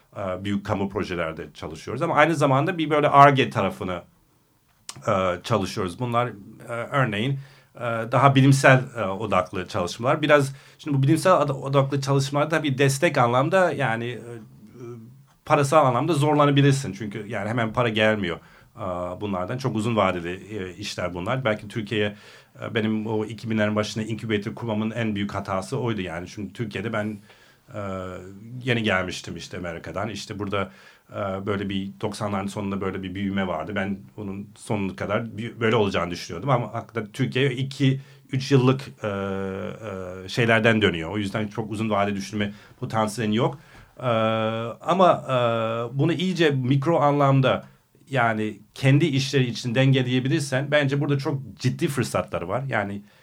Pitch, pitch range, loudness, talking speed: 115 Hz, 100-135 Hz, -23 LUFS, 135 wpm